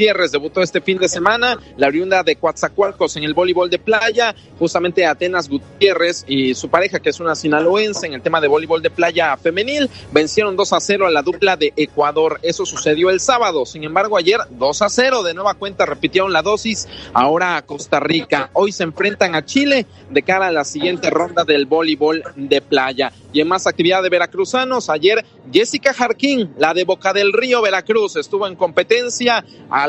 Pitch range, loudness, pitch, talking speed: 160-215 Hz, -16 LUFS, 180 Hz, 195 wpm